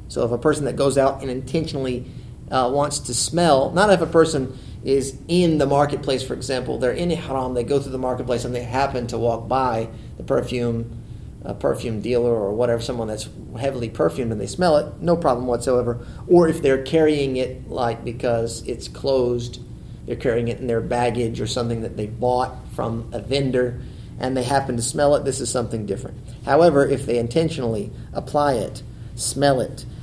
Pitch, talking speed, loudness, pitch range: 125 Hz, 190 wpm, -21 LUFS, 120-140 Hz